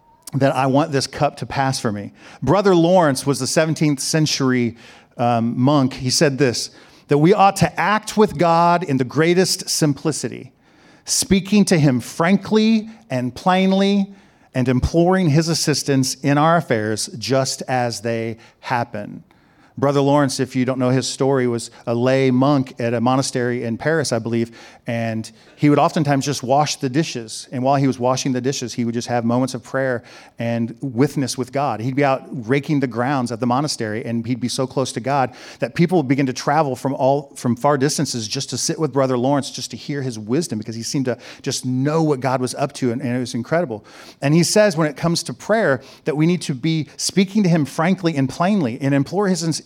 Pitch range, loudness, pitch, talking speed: 125-160 Hz, -19 LUFS, 135 Hz, 205 wpm